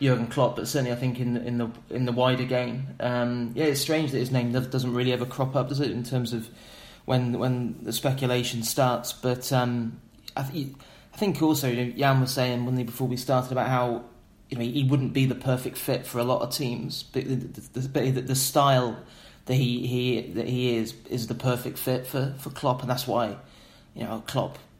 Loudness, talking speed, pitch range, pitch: -27 LUFS, 220 wpm, 120-130 Hz, 125 Hz